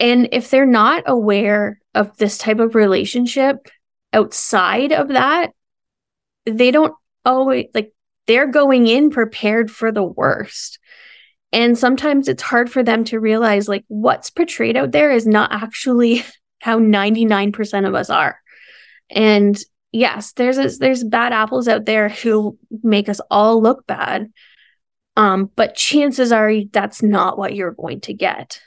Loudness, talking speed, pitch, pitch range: -16 LUFS, 155 wpm, 225 Hz, 210-255 Hz